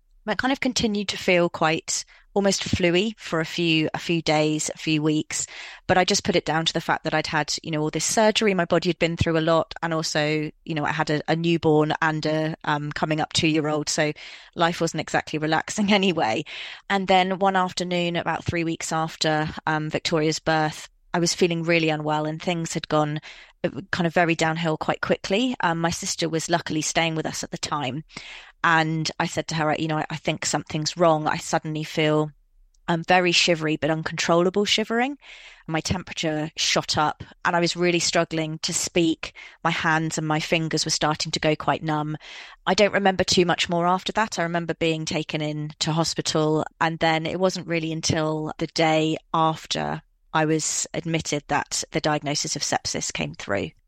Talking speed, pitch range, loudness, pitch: 200 wpm, 155-175 Hz, -23 LUFS, 160 Hz